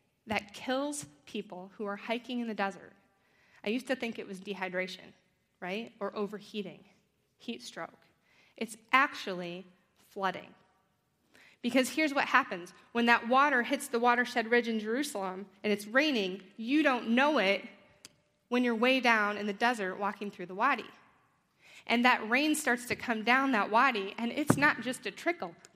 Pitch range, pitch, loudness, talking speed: 195-250 Hz, 220 Hz, -30 LUFS, 165 wpm